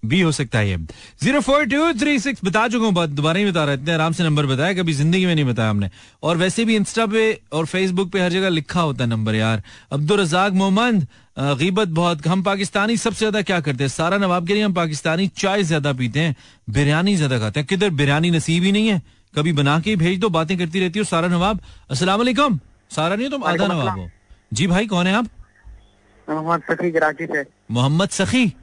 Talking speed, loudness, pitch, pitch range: 145 wpm, -19 LUFS, 170 Hz, 145-200 Hz